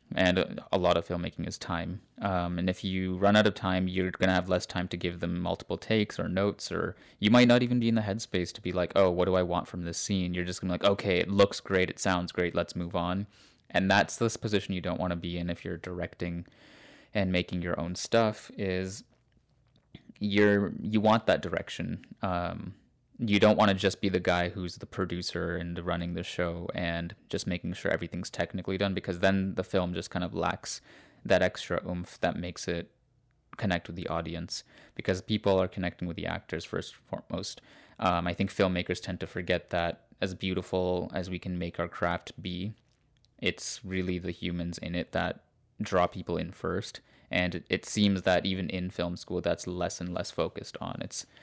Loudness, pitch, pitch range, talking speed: -30 LUFS, 90 Hz, 90-100 Hz, 210 wpm